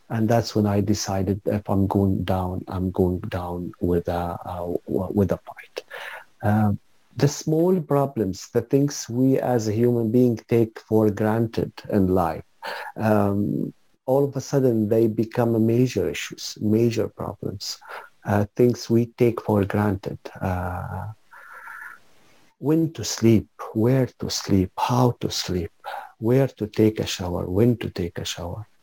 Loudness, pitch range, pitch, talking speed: -23 LUFS, 95-120 Hz, 110 Hz, 150 wpm